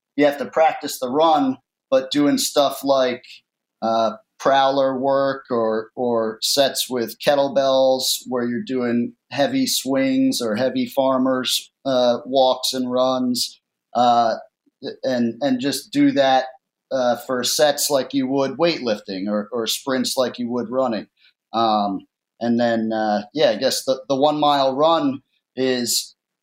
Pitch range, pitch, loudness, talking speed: 120-145 Hz, 130 Hz, -20 LUFS, 145 wpm